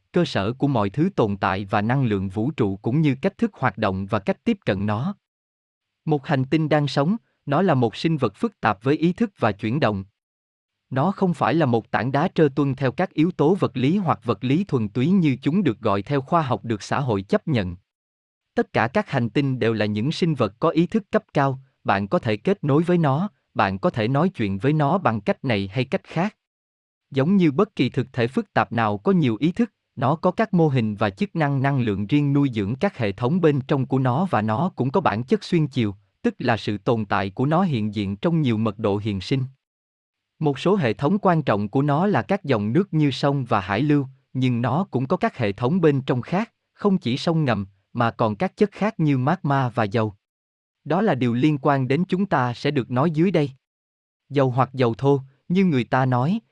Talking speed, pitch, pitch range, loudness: 240 wpm, 135 Hz, 115-170 Hz, -22 LUFS